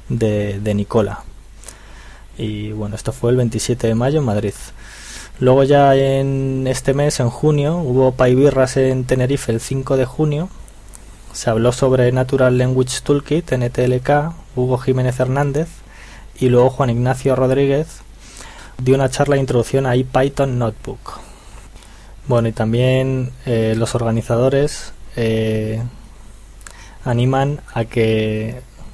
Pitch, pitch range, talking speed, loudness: 125 Hz, 115-135 Hz, 125 wpm, -17 LUFS